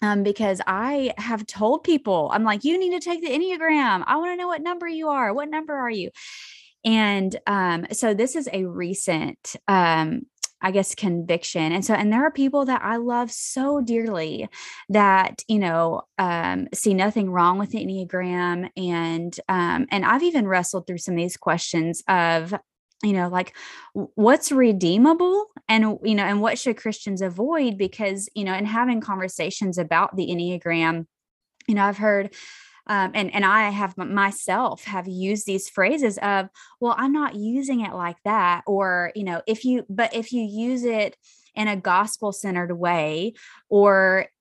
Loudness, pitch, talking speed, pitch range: -22 LUFS, 205 Hz, 175 wpm, 185-240 Hz